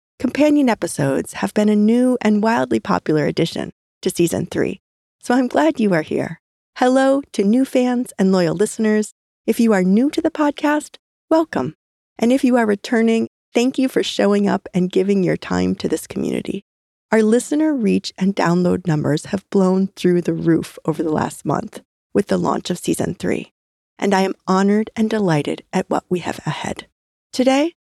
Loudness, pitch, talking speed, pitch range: -18 LUFS, 210 Hz, 180 wpm, 180-255 Hz